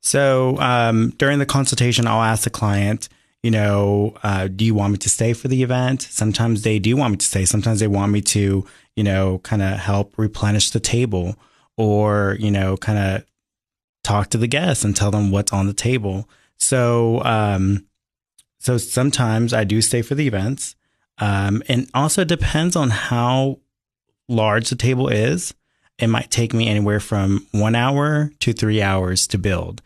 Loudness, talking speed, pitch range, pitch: -19 LUFS, 185 wpm, 100-125 Hz, 110 Hz